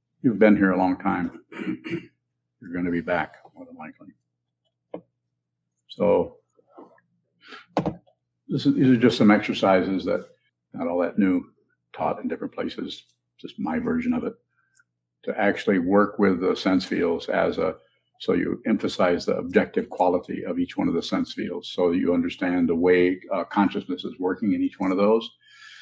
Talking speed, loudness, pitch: 165 wpm, -24 LUFS, 95 Hz